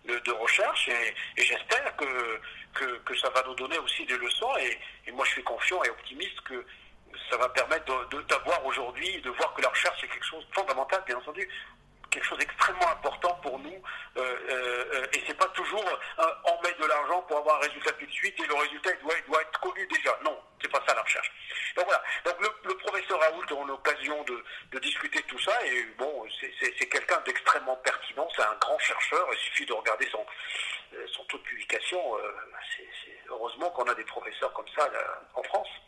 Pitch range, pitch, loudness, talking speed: 130-200 Hz, 150 Hz, -29 LUFS, 225 wpm